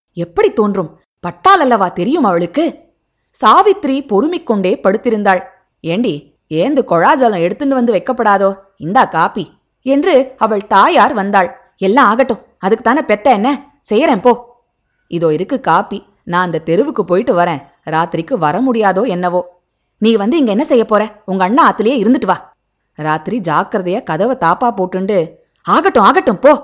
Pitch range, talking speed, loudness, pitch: 180-255 Hz, 135 wpm, -13 LUFS, 210 Hz